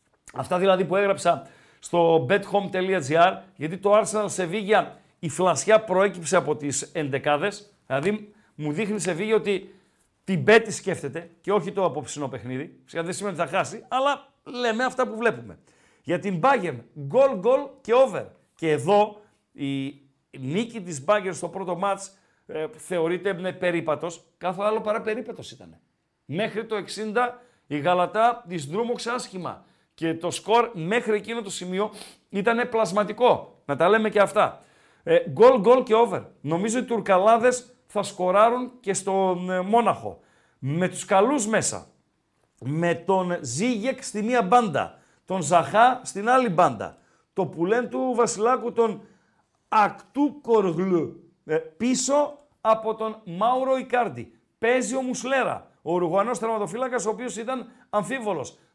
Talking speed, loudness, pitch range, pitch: 145 wpm, -24 LUFS, 175-235 Hz, 200 Hz